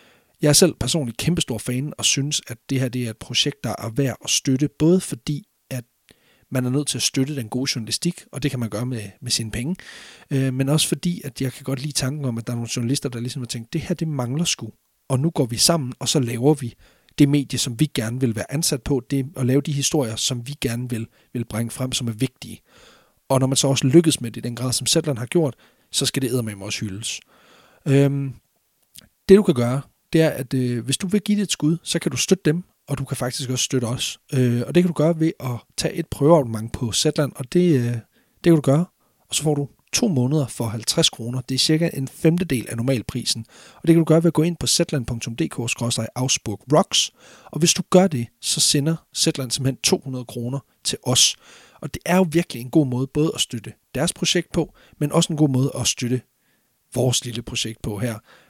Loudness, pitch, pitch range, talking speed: -21 LUFS, 135 Hz, 120-155 Hz, 240 wpm